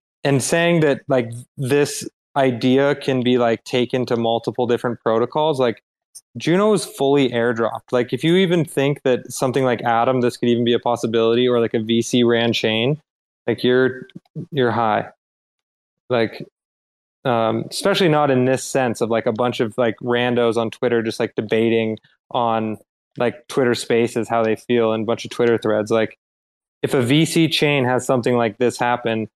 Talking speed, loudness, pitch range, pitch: 175 wpm, -19 LUFS, 115-135 Hz, 120 Hz